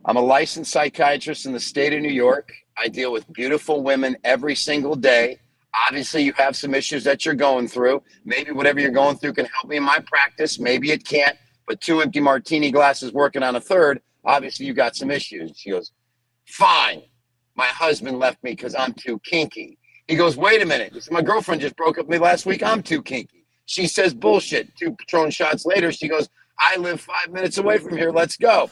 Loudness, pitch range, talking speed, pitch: -20 LUFS, 130-160 Hz, 210 wpm, 145 Hz